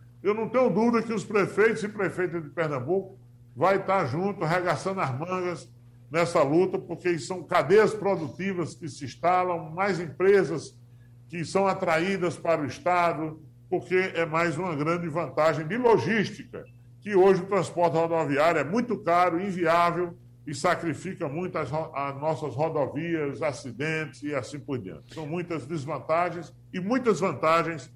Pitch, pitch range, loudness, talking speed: 170 Hz, 150-185 Hz, -26 LUFS, 150 wpm